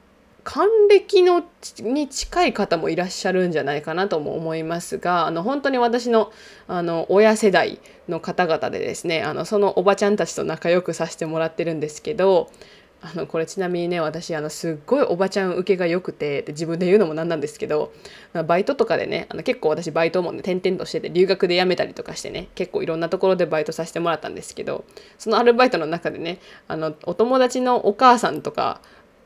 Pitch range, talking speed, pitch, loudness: 165-215 Hz, 410 characters per minute, 180 Hz, -21 LUFS